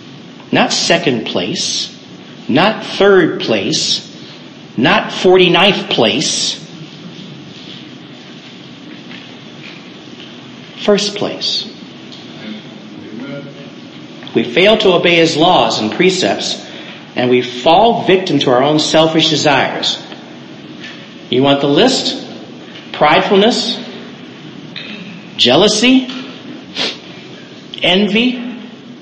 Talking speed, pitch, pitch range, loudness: 70 wpm, 200 Hz, 160-230 Hz, -12 LUFS